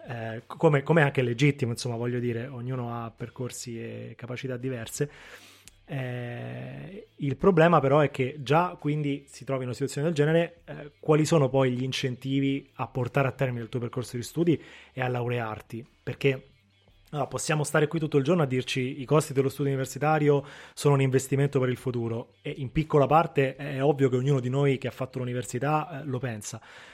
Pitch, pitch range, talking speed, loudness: 135 Hz, 125-145 Hz, 190 wpm, -27 LUFS